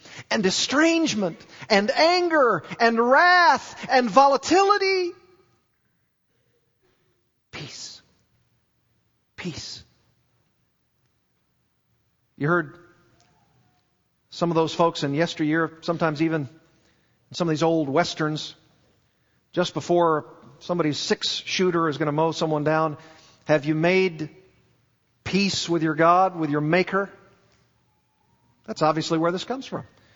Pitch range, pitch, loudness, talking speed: 155-190 Hz, 165 Hz, -22 LUFS, 105 wpm